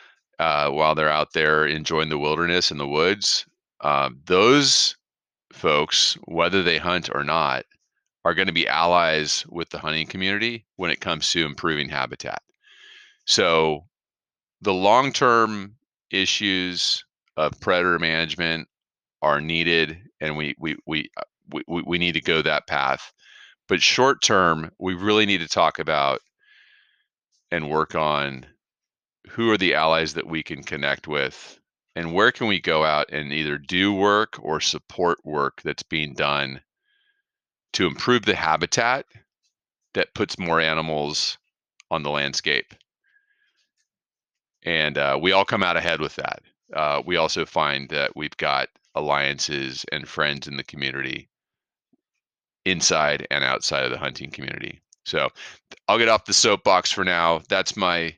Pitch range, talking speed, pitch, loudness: 75-95 Hz, 145 wpm, 80 Hz, -22 LUFS